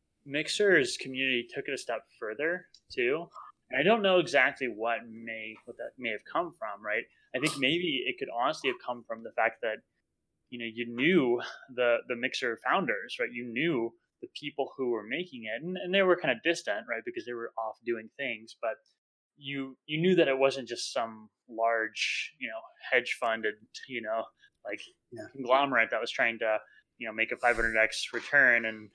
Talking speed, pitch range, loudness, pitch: 195 wpm, 115-140 Hz, -30 LUFS, 120 Hz